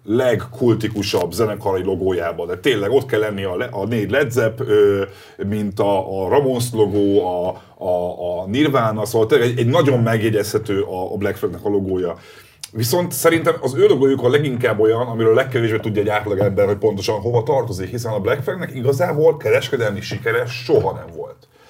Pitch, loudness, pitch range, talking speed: 115 Hz, -18 LUFS, 105-135 Hz, 175 wpm